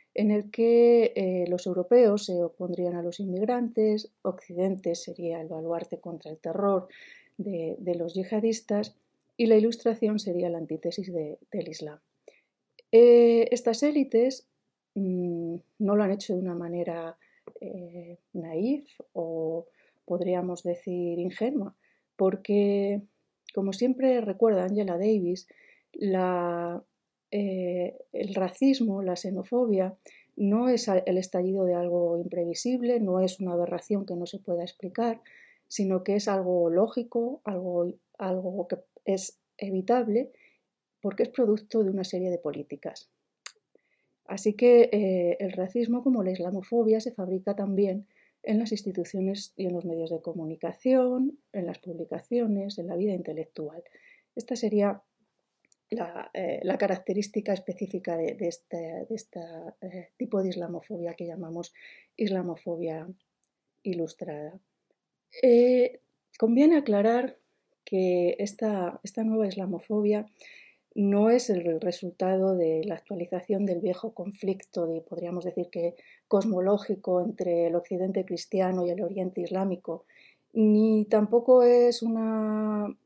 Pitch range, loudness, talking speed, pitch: 175-220 Hz, -27 LUFS, 130 wpm, 190 Hz